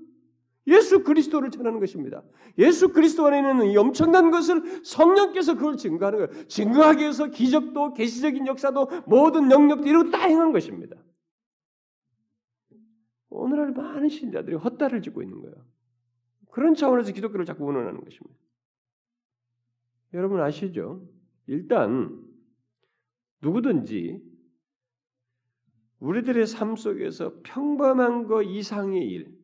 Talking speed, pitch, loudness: 285 characters per minute, 230 Hz, -22 LUFS